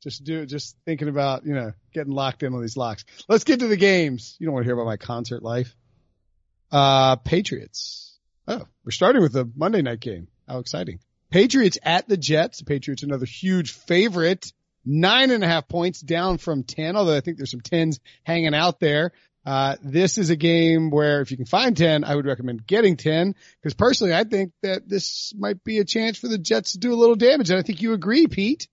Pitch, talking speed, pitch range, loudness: 160 Hz, 220 wpm, 130-190 Hz, -21 LUFS